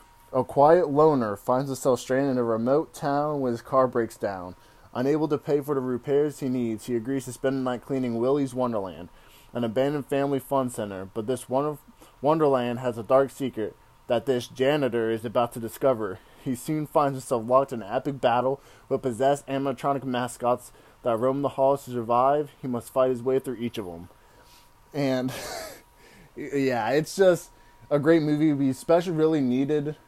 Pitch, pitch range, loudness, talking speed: 130 Hz, 120-140 Hz, -25 LUFS, 180 wpm